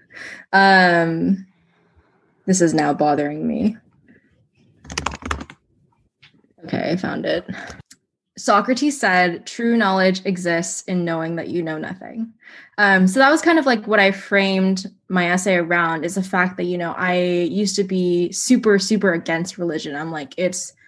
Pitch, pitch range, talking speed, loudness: 185 Hz, 170-205 Hz, 145 wpm, -19 LUFS